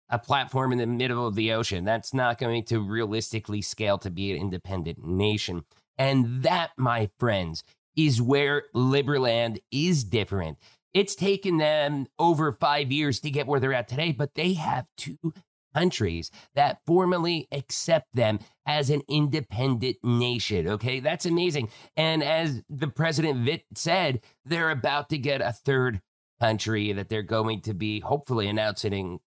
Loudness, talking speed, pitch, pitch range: -26 LUFS, 155 wpm, 125 Hz, 110-150 Hz